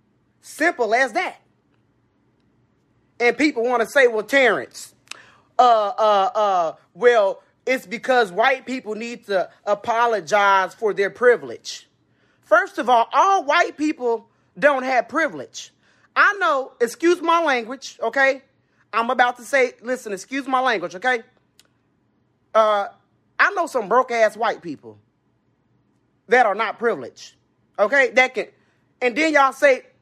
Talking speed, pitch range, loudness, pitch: 135 wpm, 220-275 Hz, -19 LUFS, 245 Hz